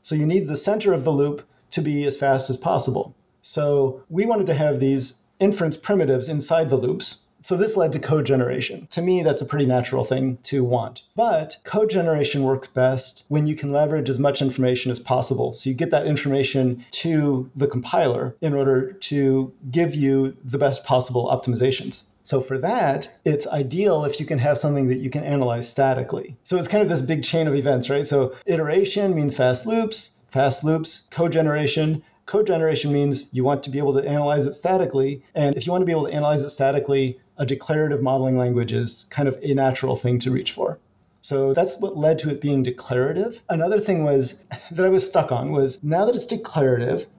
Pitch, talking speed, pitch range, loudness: 140 Hz, 205 wpm, 130-160 Hz, -22 LUFS